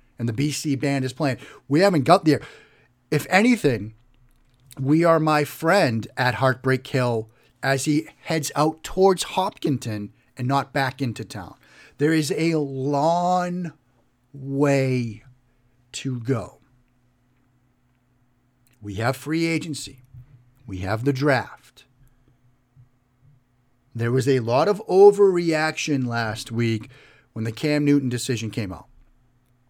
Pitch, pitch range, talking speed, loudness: 130 Hz, 125-145 Hz, 120 wpm, -22 LUFS